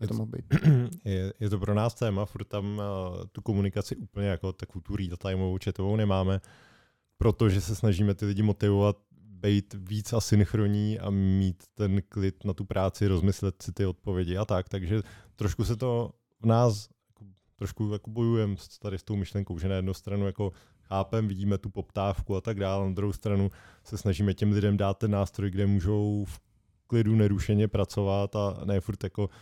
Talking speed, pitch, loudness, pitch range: 175 wpm, 100 Hz, -29 LUFS, 95-105 Hz